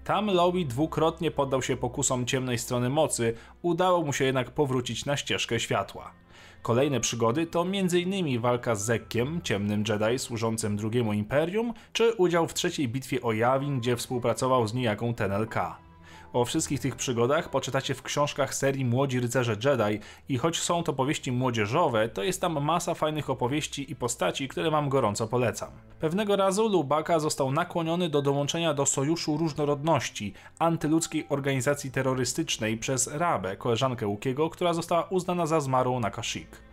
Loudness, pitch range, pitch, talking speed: -27 LUFS, 120-160 Hz, 135 Hz, 155 wpm